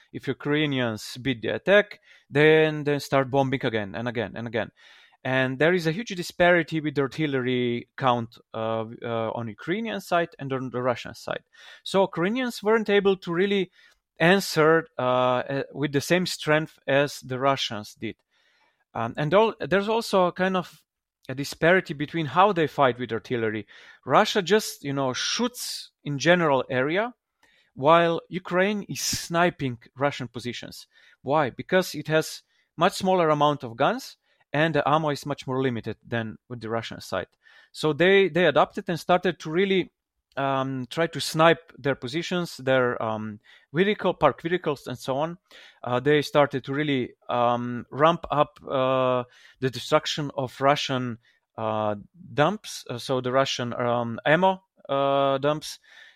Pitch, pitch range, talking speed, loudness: 145 Hz, 125-175 Hz, 155 wpm, -25 LUFS